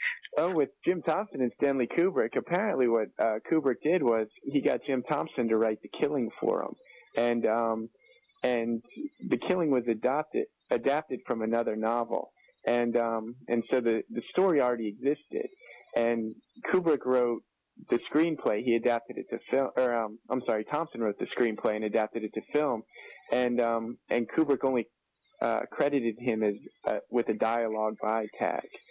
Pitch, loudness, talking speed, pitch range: 120 Hz, -30 LUFS, 170 wpm, 115-140 Hz